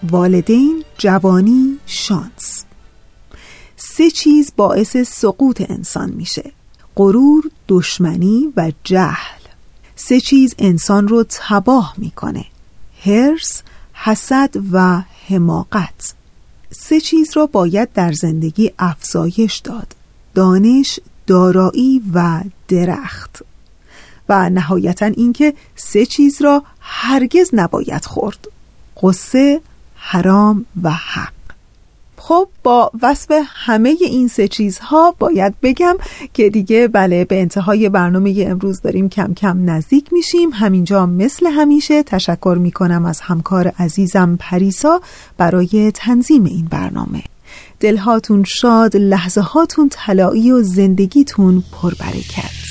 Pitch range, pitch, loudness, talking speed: 185-265 Hz, 205 Hz, -13 LUFS, 100 wpm